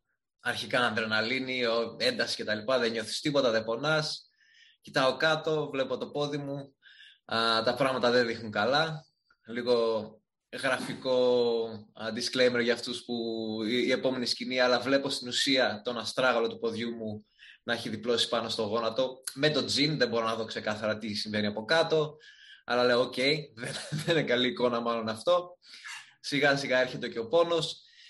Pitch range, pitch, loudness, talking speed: 115-145 Hz, 125 Hz, -29 LUFS, 160 wpm